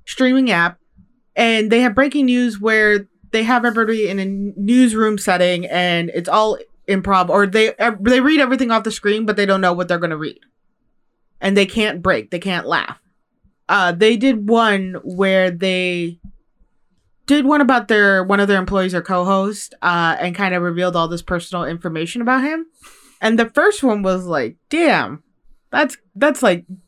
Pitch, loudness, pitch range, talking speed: 200 Hz, -16 LUFS, 180-240 Hz, 180 wpm